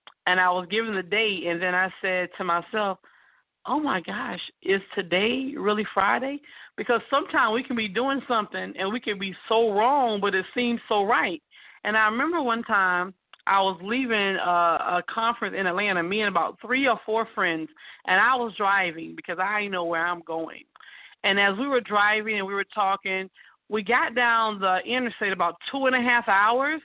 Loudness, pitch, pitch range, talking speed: -24 LUFS, 210 Hz, 190-240 Hz, 195 wpm